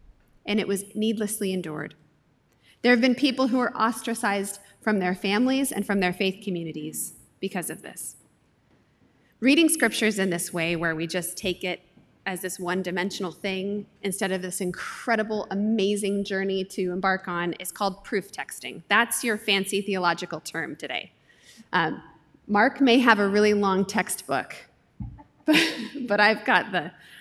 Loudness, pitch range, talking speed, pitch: -25 LUFS, 180-215 Hz, 155 wpm, 195 Hz